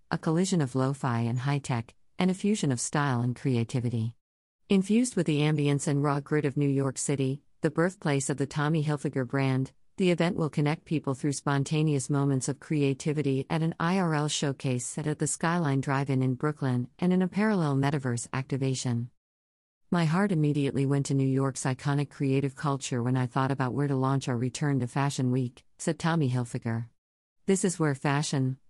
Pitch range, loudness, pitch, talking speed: 130-155 Hz, -28 LUFS, 140 Hz, 190 wpm